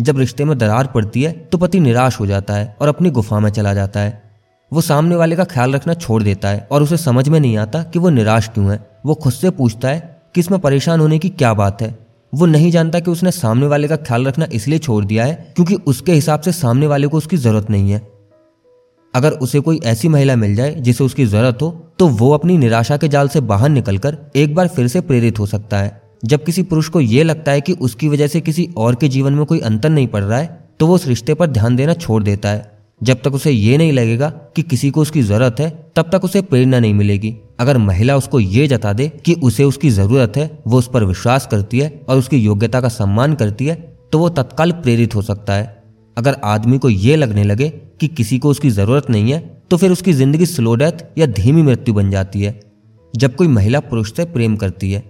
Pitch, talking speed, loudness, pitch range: 135 Hz, 240 wpm, -14 LUFS, 115-155 Hz